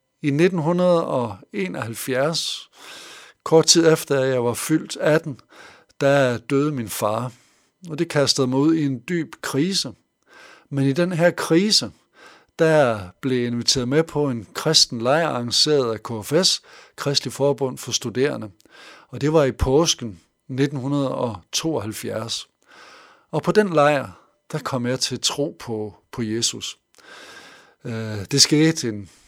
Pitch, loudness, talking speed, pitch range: 135 Hz, -20 LUFS, 130 wpm, 120-155 Hz